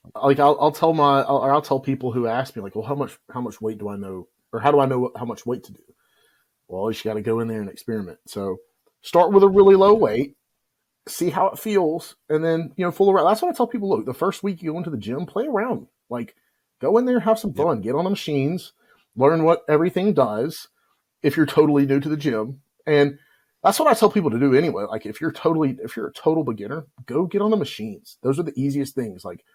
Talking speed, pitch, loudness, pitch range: 260 wpm, 150 Hz, -21 LUFS, 135-195 Hz